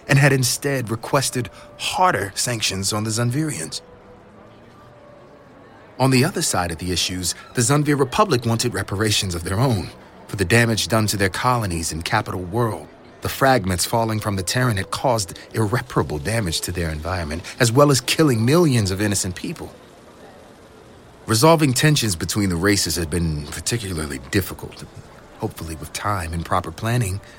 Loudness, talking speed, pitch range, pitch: -20 LUFS, 155 wpm, 95-125 Hz, 110 Hz